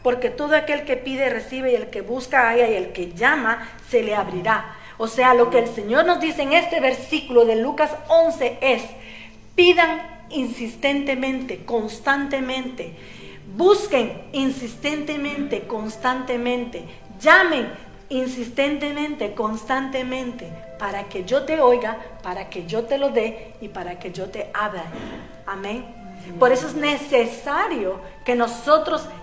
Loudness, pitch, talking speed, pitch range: -21 LUFS, 250 Hz, 135 wpm, 225-280 Hz